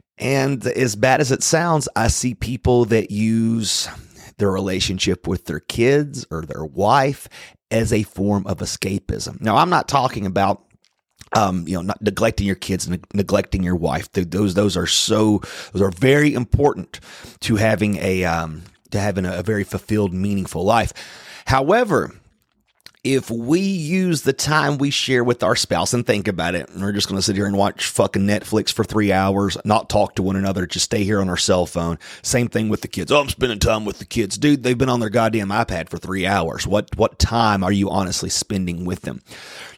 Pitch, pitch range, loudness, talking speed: 105 Hz, 95-120 Hz, -19 LUFS, 200 wpm